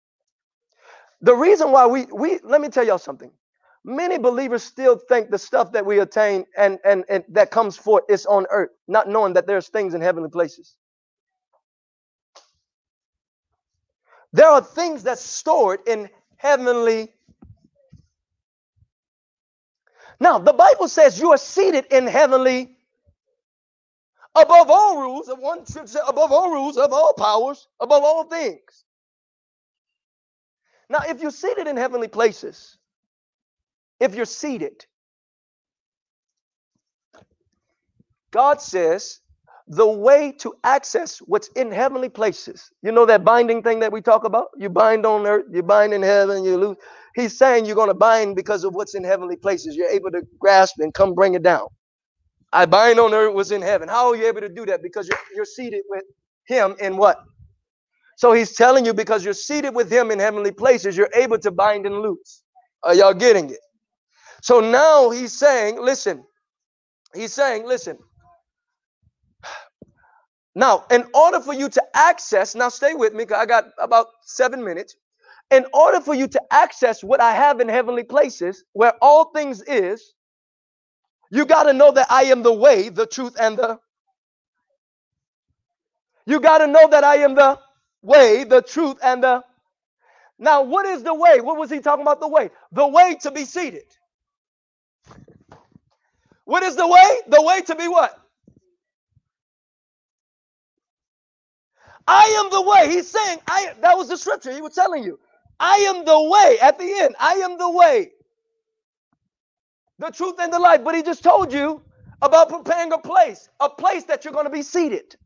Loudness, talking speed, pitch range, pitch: -17 LUFS, 160 wpm, 220-335 Hz, 270 Hz